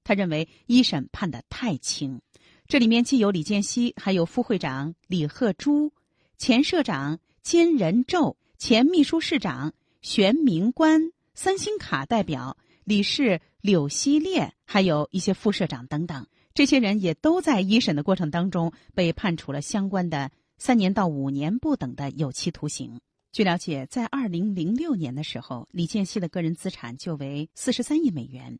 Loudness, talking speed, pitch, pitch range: -24 LUFS, 250 characters per minute, 195 Hz, 155-250 Hz